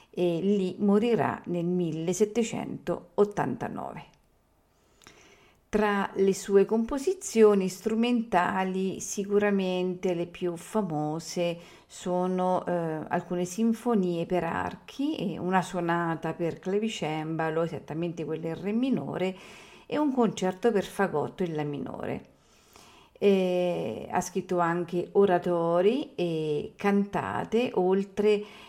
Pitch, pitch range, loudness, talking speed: 185 Hz, 170-205 Hz, -28 LUFS, 95 wpm